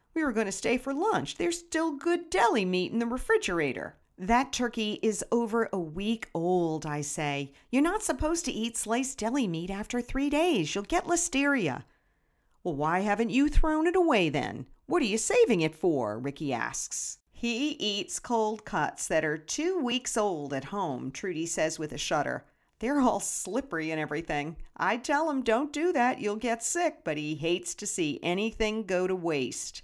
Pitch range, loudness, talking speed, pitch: 170-280 Hz, -29 LUFS, 185 wpm, 225 Hz